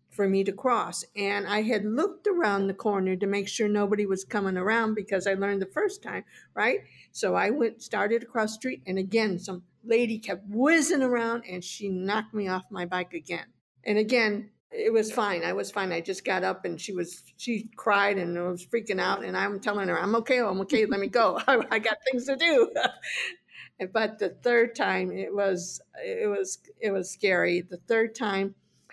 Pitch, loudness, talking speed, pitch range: 210 Hz, -27 LUFS, 205 wpm, 195-240 Hz